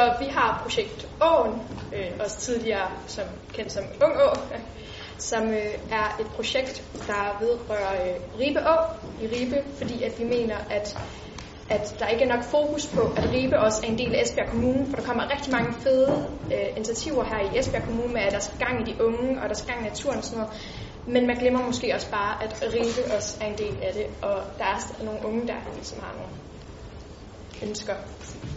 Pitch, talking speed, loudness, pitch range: 235 Hz, 210 wpm, -26 LUFS, 215-265 Hz